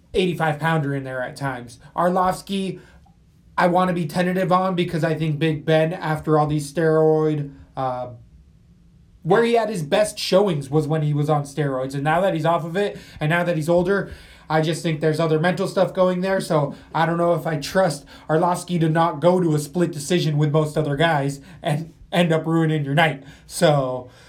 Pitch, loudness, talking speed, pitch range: 160 Hz, -21 LUFS, 200 wpm, 150-180 Hz